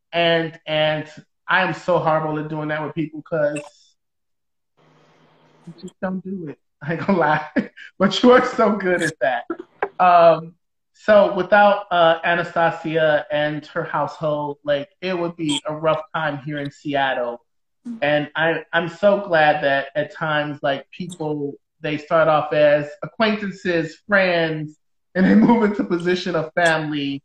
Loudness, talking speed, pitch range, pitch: -19 LUFS, 150 wpm, 150-180 Hz, 160 Hz